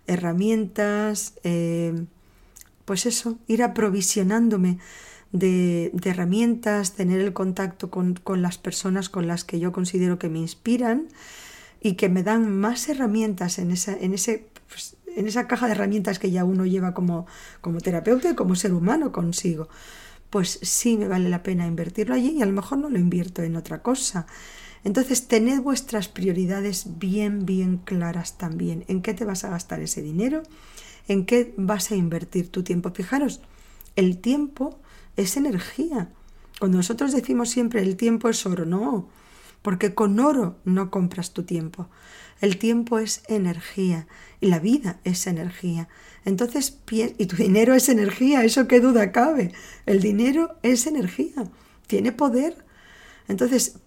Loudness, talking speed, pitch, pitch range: -23 LUFS, 155 wpm, 200 Hz, 180-235 Hz